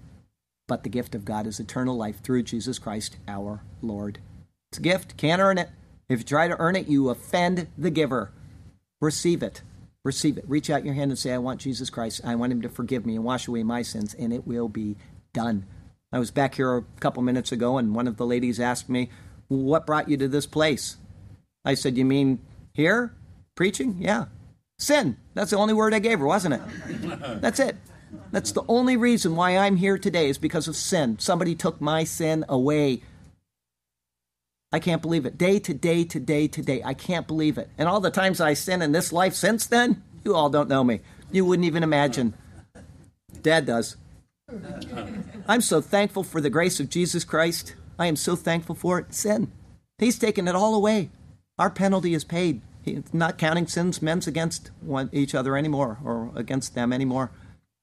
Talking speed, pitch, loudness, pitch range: 200 wpm, 140 Hz, -25 LUFS, 115-170 Hz